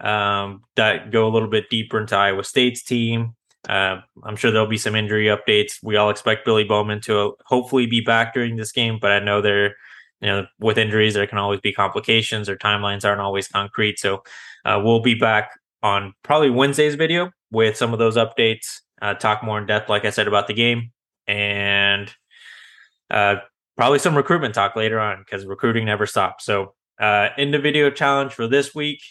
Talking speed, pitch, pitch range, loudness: 195 wpm, 110 Hz, 100-115 Hz, -19 LUFS